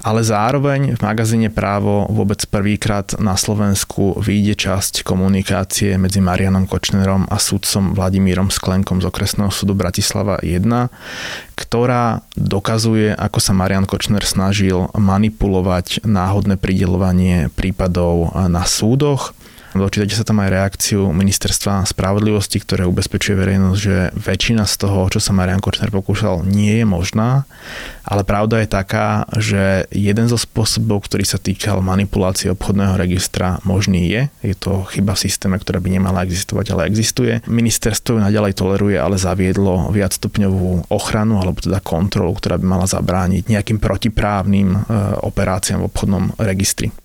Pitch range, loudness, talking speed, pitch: 95-105 Hz, -16 LUFS, 135 wpm, 100 Hz